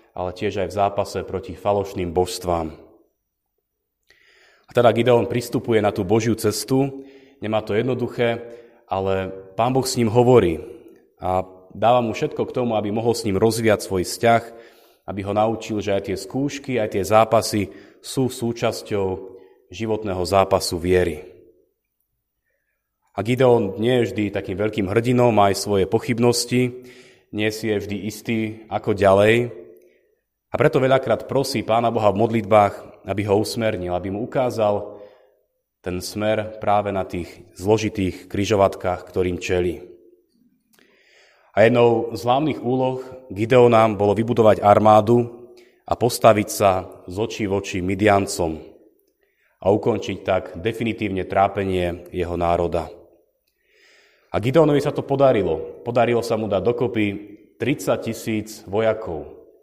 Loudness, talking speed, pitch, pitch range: -20 LUFS, 135 wpm, 110 Hz, 95-120 Hz